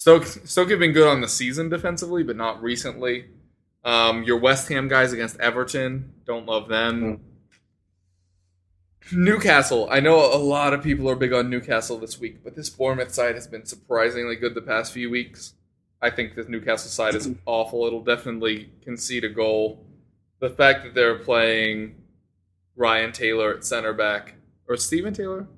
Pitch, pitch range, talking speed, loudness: 120 Hz, 110-130 Hz, 170 wpm, -22 LUFS